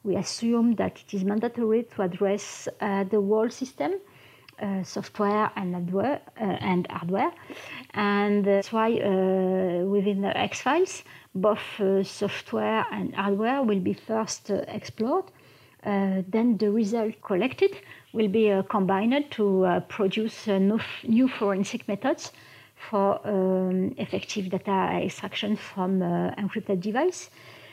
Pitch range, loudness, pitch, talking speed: 195-225 Hz, -26 LUFS, 205 Hz, 130 wpm